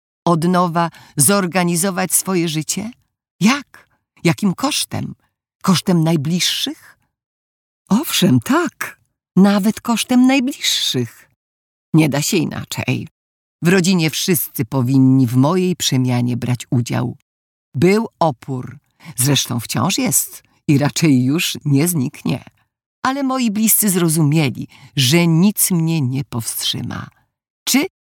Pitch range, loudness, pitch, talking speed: 130-190 Hz, -16 LUFS, 165 Hz, 105 wpm